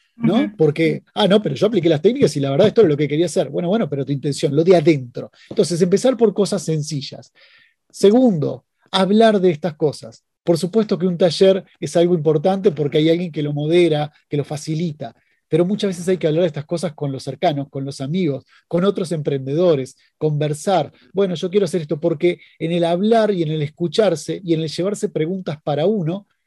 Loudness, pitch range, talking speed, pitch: -18 LUFS, 150-195 Hz, 210 wpm, 170 Hz